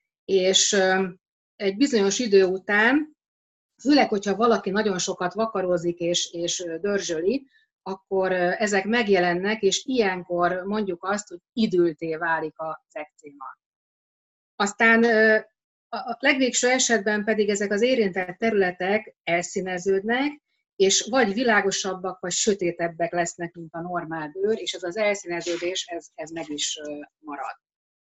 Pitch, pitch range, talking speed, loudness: 195 Hz, 175-220 Hz, 120 wpm, -23 LUFS